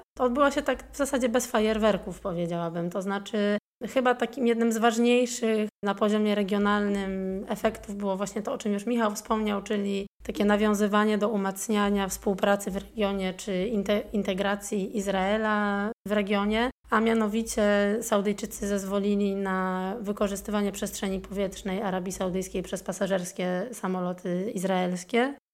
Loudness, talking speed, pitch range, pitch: -27 LUFS, 130 wpm, 195-220 Hz, 205 Hz